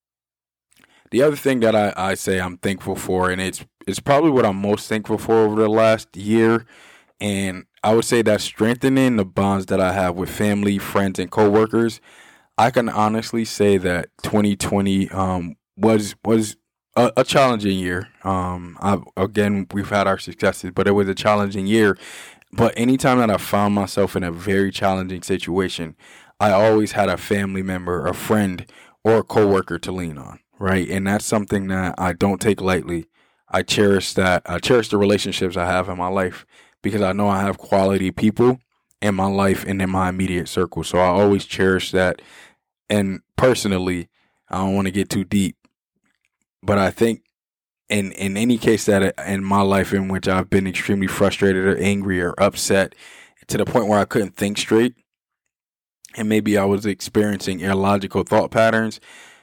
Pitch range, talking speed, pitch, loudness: 95-105 Hz, 180 wpm, 100 Hz, -19 LUFS